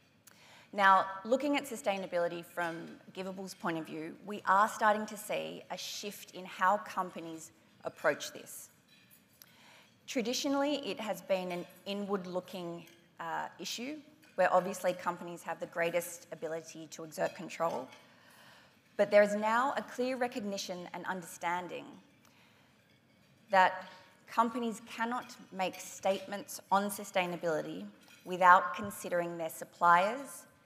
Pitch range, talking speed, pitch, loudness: 175-210 Hz, 115 wpm, 185 Hz, -33 LUFS